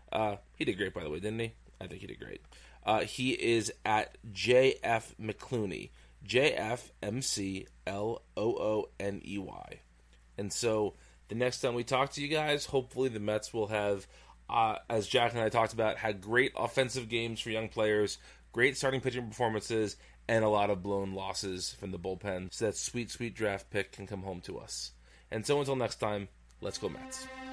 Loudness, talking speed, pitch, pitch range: -33 LUFS, 200 wpm, 110 Hz, 100-125 Hz